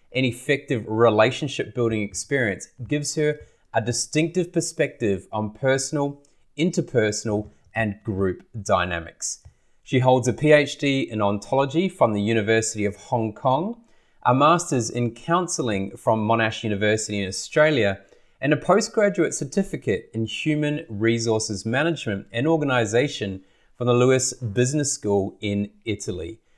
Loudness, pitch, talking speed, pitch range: -23 LUFS, 120 Hz, 120 wpm, 110-150 Hz